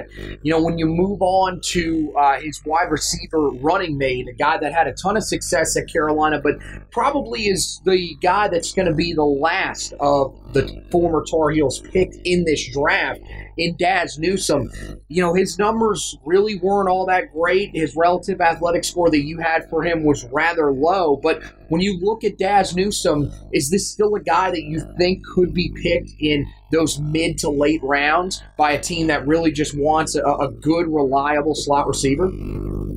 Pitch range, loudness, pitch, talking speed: 150-180 Hz, -19 LUFS, 160 Hz, 190 wpm